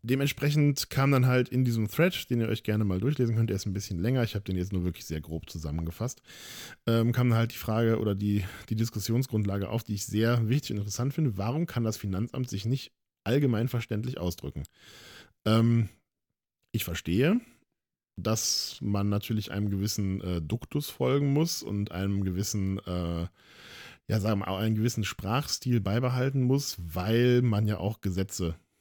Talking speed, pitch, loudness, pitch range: 175 wpm, 110 Hz, -29 LUFS, 100-125 Hz